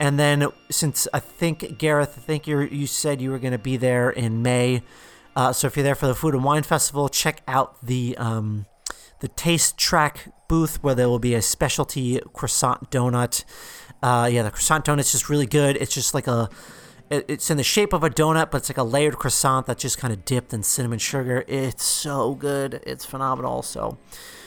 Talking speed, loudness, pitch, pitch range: 210 wpm, -22 LUFS, 135 Hz, 125-145 Hz